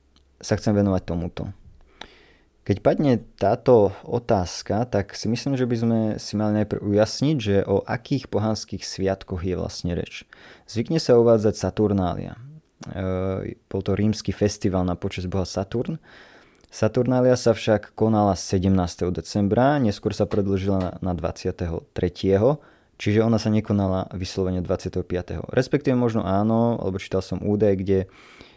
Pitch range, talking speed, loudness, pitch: 95-110 Hz, 135 wpm, -23 LUFS, 100 Hz